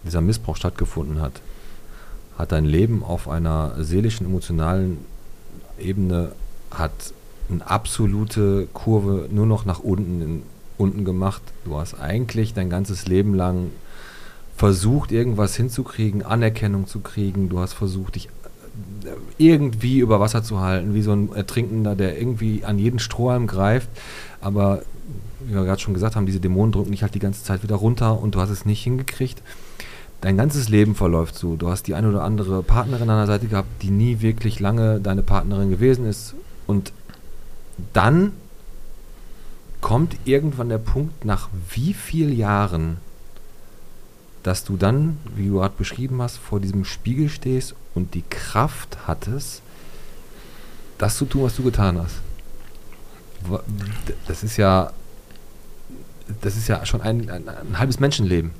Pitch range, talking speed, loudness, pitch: 95-115 Hz, 150 wpm, -22 LUFS, 105 Hz